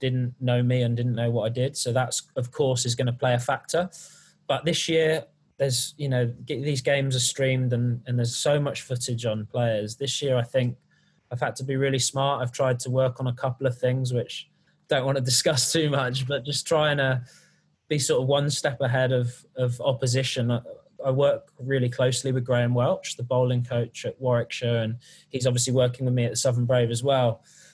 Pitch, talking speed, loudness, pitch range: 130 Hz, 215 wpm, -25 LUFS, 120-140 Hz